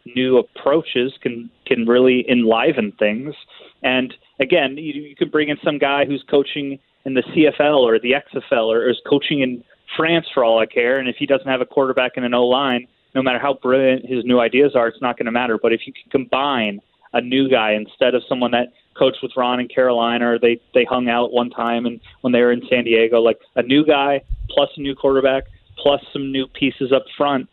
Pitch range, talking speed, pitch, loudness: 120-140 Hz, 220 wpm, 130 Hz, -18 LUFS